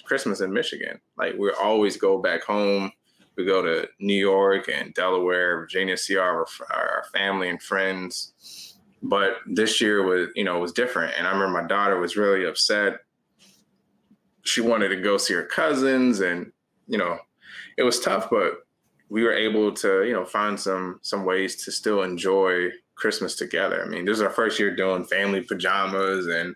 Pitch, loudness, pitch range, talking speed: 95 Hz, -23 LUFS, 90-105 Hz, 185 wpm